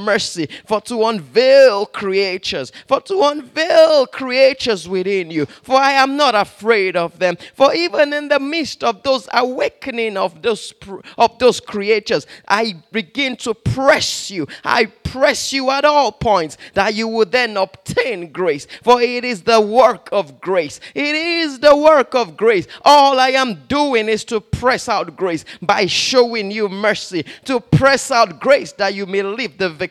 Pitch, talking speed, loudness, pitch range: 230 Hz, 170 wpm, -16 LUFS, 200-270 Hz